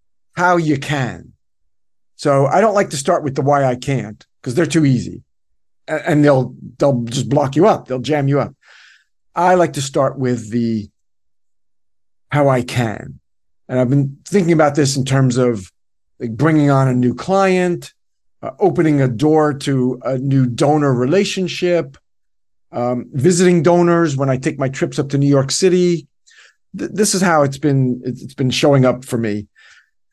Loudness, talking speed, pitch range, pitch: -16 LUFS, 175 wpm, 120-155 Hz, 135 Hz